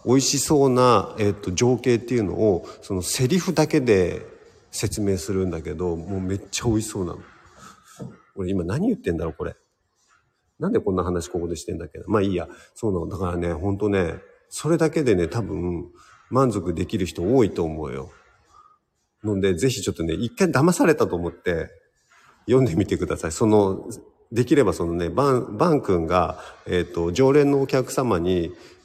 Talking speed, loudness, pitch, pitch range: 345 characters per minute, -22 LUFS, 100 Hz, 90-130 Hz